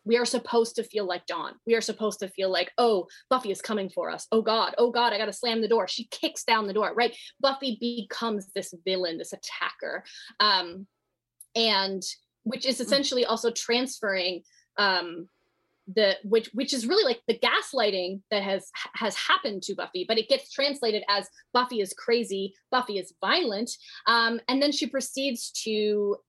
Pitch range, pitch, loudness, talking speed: 195-240 Hz, 225 Hz, -27 LUFS, 180 wpm